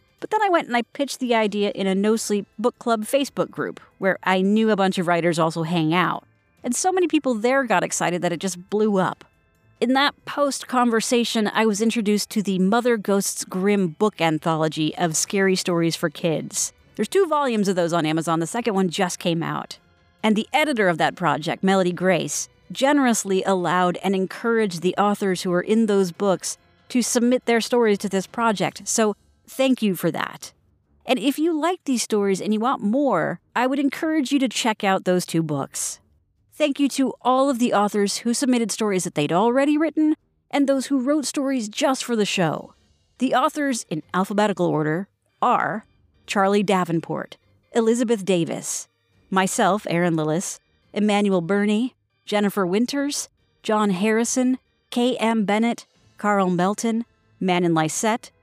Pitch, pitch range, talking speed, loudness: 210 Hz, 185-245 Hz, 175 wpm, -22 LUFS